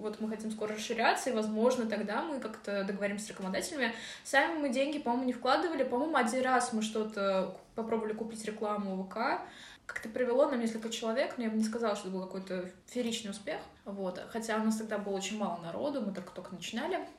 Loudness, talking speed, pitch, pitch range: -34 LUFS, 195 wpm, 220 Hz, 205-250 Hz